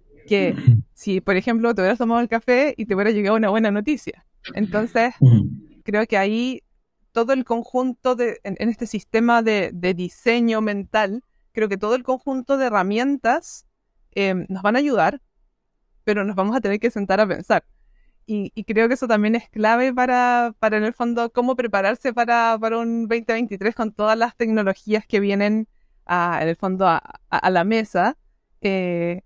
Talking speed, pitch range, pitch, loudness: 180 wpm, 200-235 Hz, 220 Hz, -20 LUFS